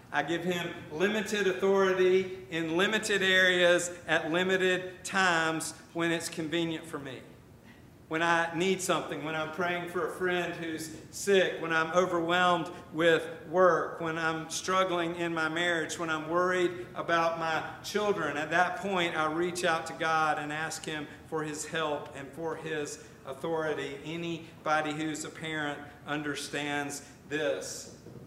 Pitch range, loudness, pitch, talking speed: 155-180 Hz, -30 LUFS, 165 Hz, 145 wpm